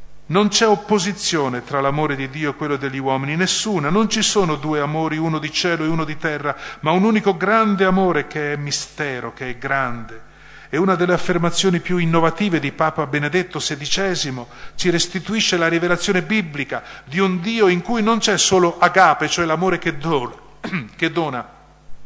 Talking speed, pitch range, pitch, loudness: 175 wpm, 145-190 Hz, 165 Hz, -19 LUFS